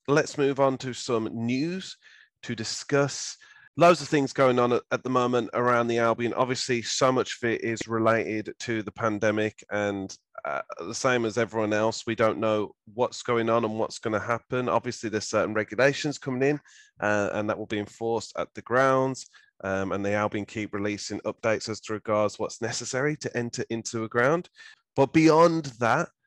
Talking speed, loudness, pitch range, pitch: 185 wpm, -26 LUFS, 110-130 Hz, 115 Hz